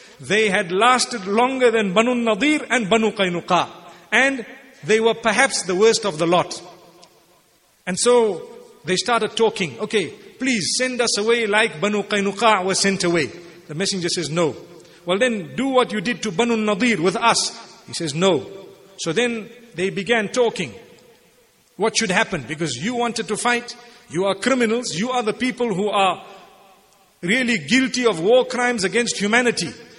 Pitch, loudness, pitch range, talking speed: 220 Hz, -19 LUFS, 190-240 Hz, 165 wpm